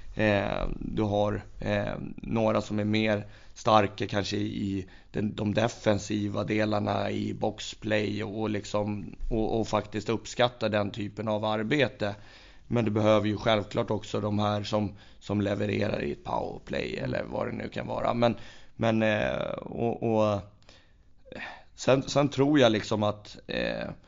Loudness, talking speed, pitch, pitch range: -29 LUFS, 150 wpm, 105 Hz, 105-110 Hz